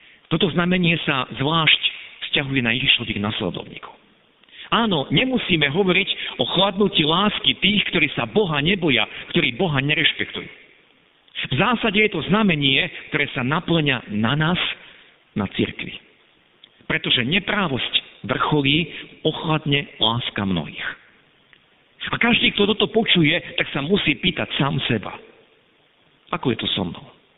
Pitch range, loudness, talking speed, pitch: 140-190 Hz, -20 LUFS, 125 wpm, 155 Hz